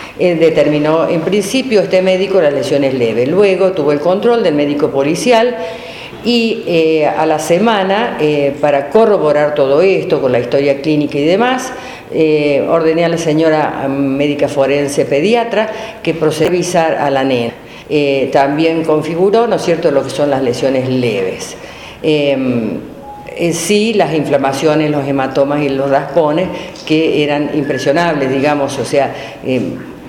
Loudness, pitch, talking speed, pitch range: -13 LUFS, 155 Hz, 150 wpm, 140-180 Hz